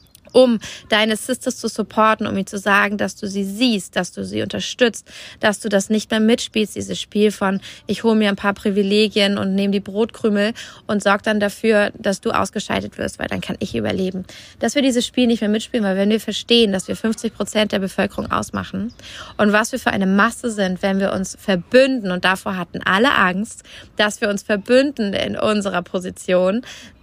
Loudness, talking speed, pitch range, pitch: -19 LUFS, 200 wpm, 195-225 Hz, 210 Hz